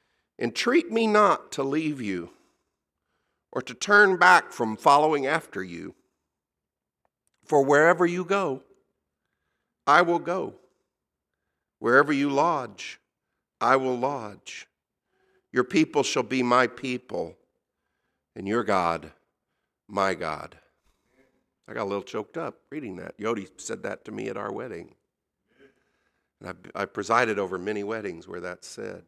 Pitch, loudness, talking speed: 135 Hz, -24 LUFS, 130 wpm